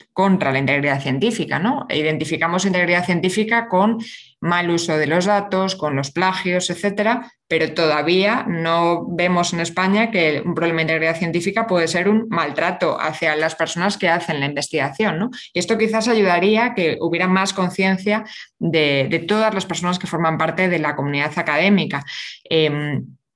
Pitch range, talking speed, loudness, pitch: 160-195 Hz, 165 wpm, -19 LUFS, 175 Hz